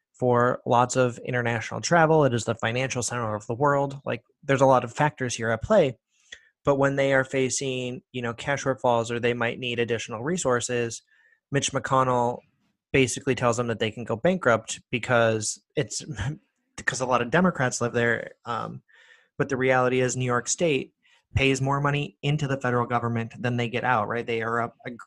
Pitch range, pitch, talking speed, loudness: 120-135 Hz, 125 Hz, 190 wpm, -25 LUFS